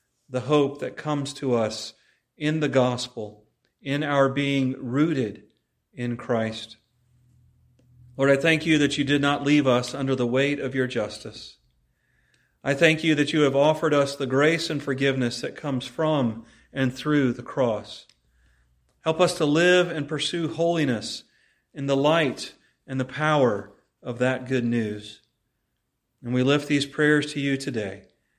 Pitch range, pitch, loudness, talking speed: 120-150 Hz, 135 Hz, -24 LUFS, 160 wpm